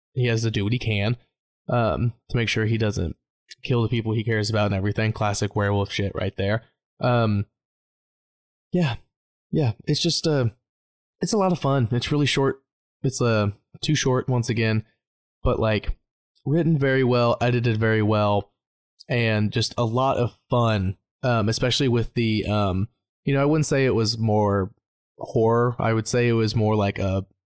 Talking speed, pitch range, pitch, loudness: 180 wpm, 105-125 Hz, 115 Hz, -23 LUFS